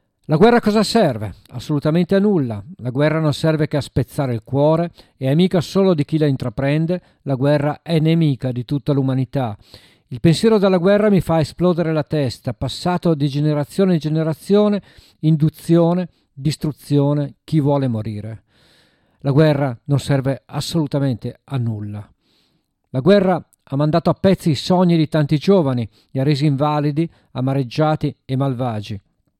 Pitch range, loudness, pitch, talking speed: 135-165 Hz, -18 LUFS, 150 Hz, 155 wpm